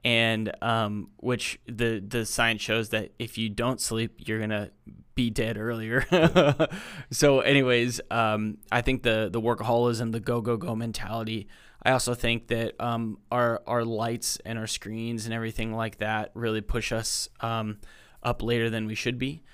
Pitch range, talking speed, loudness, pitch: 110-120 Hz, 170 wpm, -27 LUFS, 115 Hz